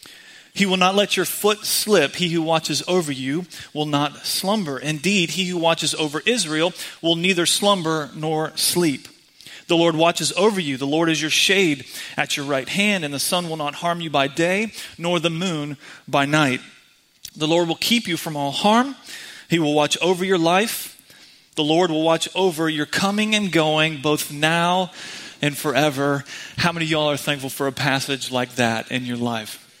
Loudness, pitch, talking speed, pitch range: -20 LUFS, 160 Hz, 190 wpm, 145-185 Hz